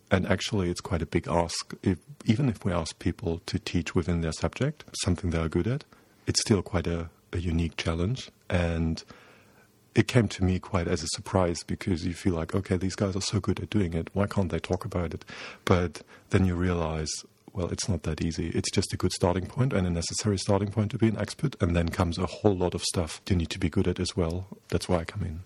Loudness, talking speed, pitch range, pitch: -29 LUFS, 245 wpm, 85-105 Hz, 90 Hz